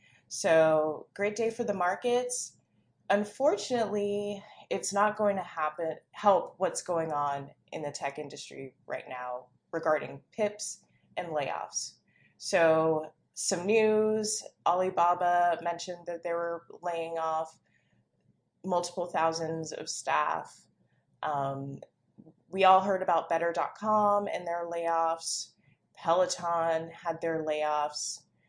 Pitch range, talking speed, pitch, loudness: 160-195 Hz, 110 wpm, 170 Hz, -30 LUFS